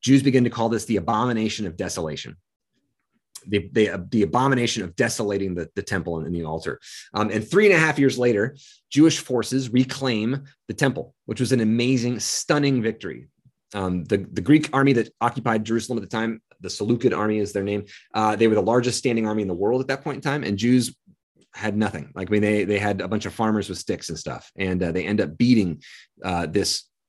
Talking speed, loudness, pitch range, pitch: 215 wpm, -23 LUFS, 100-125 Hz, 110 Hz